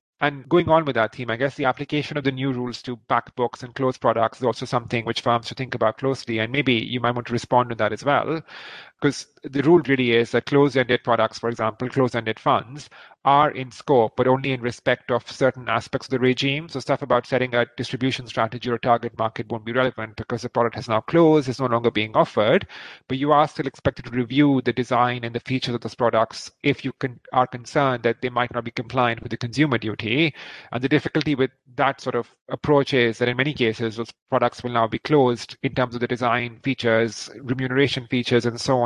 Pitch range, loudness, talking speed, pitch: 120-135 Hz, -22 LUFS, 235 wpm, 125 Hz